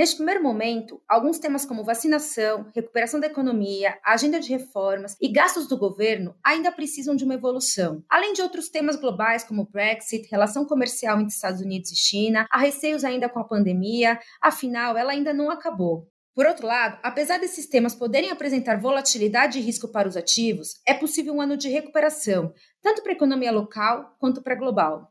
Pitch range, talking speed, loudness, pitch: 215-290 Hz, 180 wpm, -23 LUFS, 245 Hz